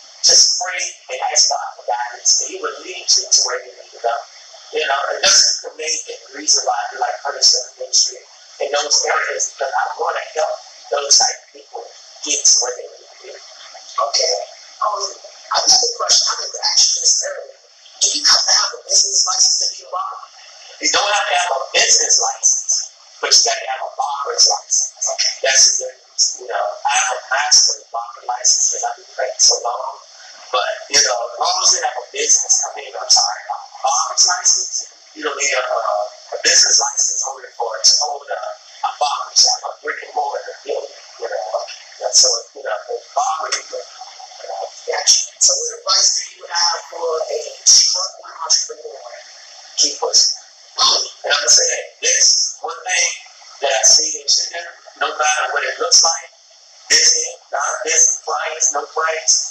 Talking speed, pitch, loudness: 200 wpm, 390 Hz, -14 LUFS